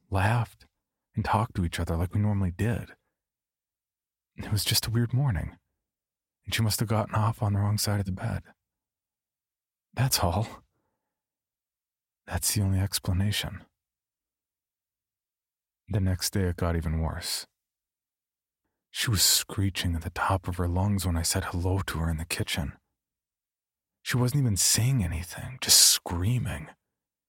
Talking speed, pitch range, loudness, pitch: 145 wpm, 90-110 Hz, -26 LUFS, 95 Hz